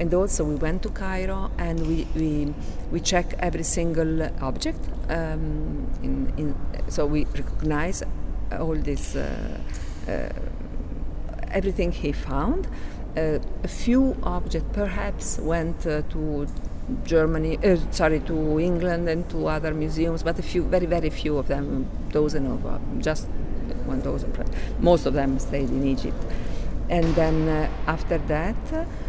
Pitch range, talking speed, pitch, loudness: 145-170 Hz, 150 wpm, 160 Hz, -26 LUFS